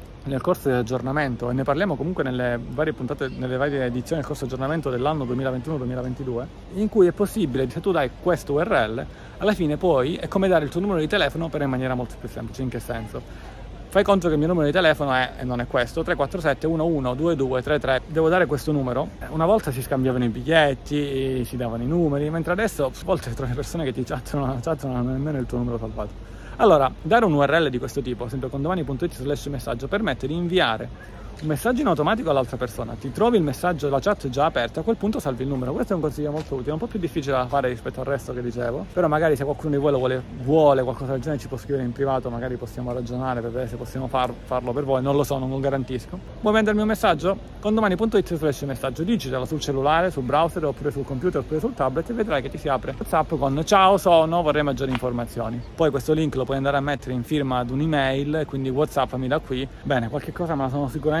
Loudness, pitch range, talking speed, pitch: -23 LUFS, 130-160 Hz, 235 wpm, 140 Hz